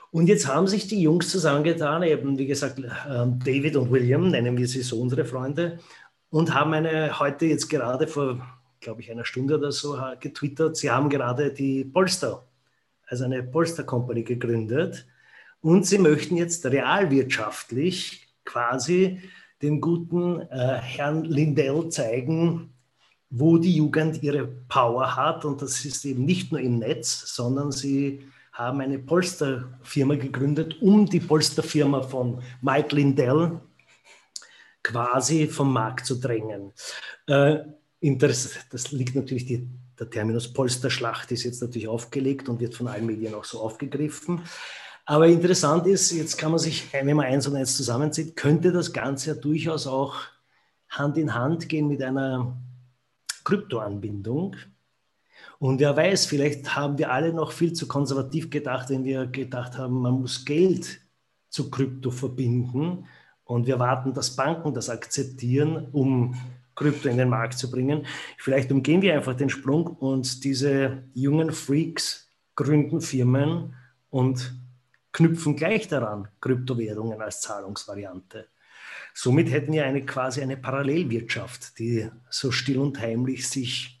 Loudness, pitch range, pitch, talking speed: -25 LUFS, 125-155 Hz, 140 Hz, 140 wpm